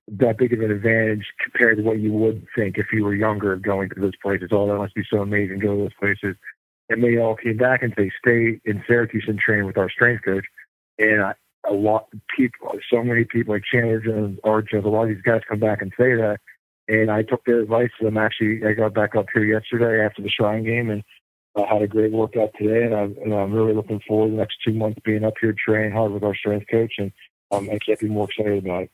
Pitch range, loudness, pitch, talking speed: 105-110 Hz, -21 LUFS, 110 Hz, 255 wpm